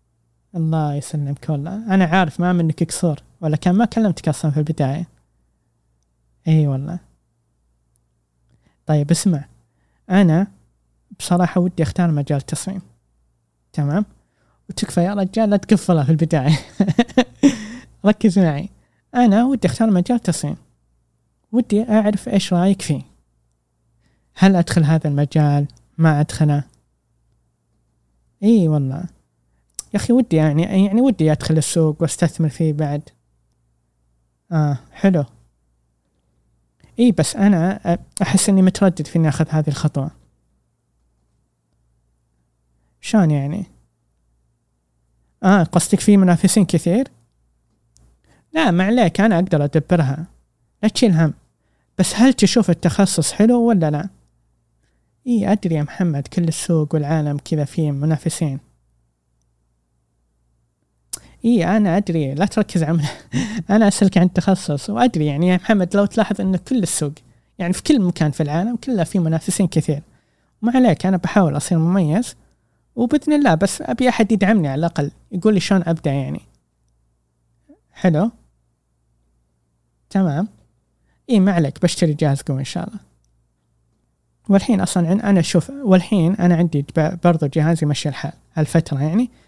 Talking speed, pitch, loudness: 120 wpm, 160 Hz, -18 LUFS